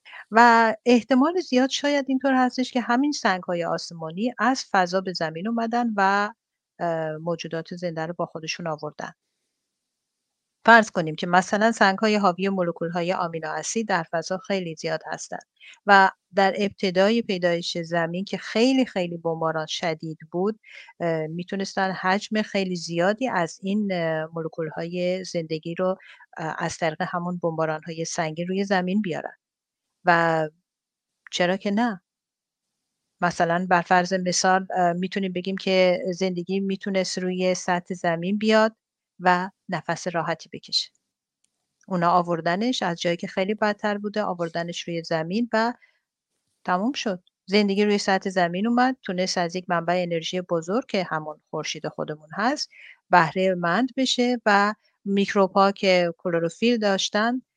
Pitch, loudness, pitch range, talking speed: 185 Hz, -24 LUFS, 170-210 Hz, 135 wpm